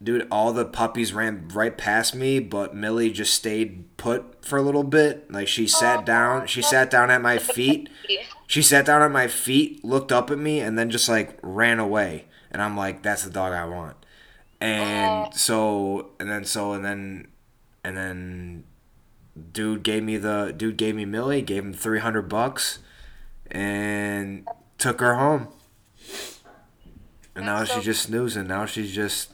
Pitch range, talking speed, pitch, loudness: 100-120 Hz, 170 wpm, 110 Hz, -23 LUFS